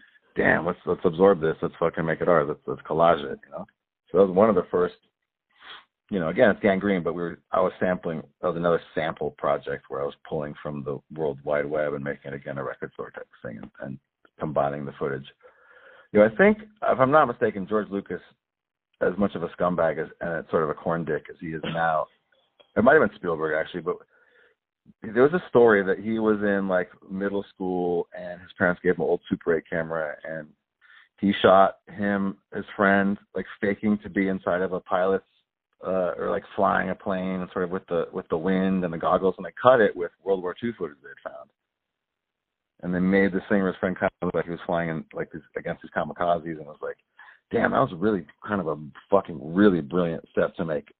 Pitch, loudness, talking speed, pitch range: 95 Hz, -25 LUFS, 230 wpm, 85-100 Hz